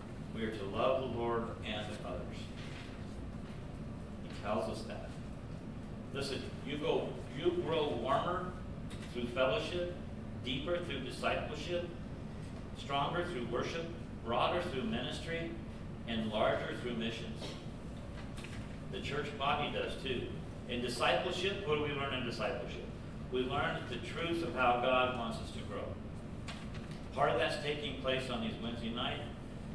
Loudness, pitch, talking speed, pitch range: -38 LUFS, 120 Hz, 135 wpm, 110-130 Hz